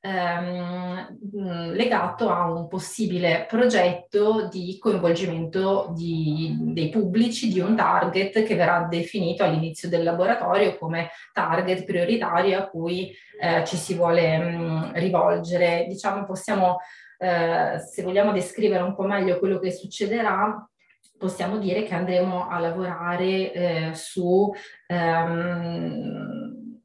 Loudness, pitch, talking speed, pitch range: -24 LUFS, 180 Hz, 115 wpm, 170-200 Hz